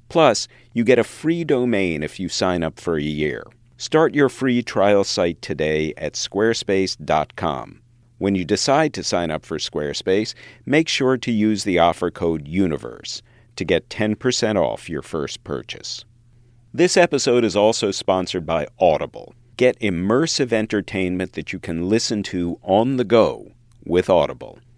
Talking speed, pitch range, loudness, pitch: 155 wpm, 90-120 Hz, -20 LUFS, 110 Hz